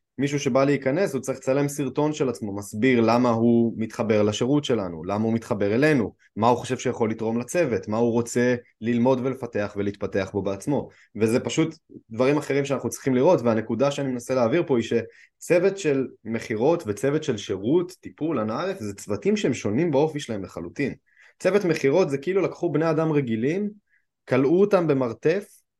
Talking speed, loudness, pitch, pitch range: 165 wpm, -24 LUFS, 130 Hz, 115-145 Hz